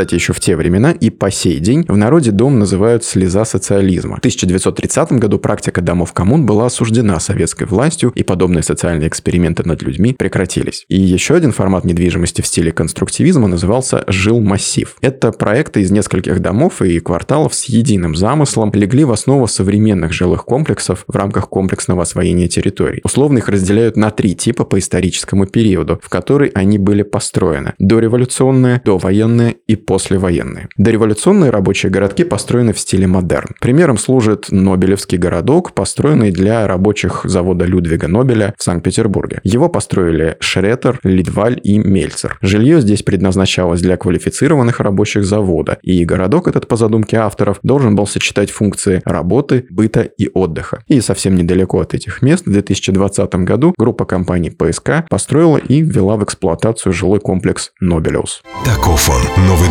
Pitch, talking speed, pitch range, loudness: 100 Hz, 150 wpm, 95-115 Hz, -13 LUFS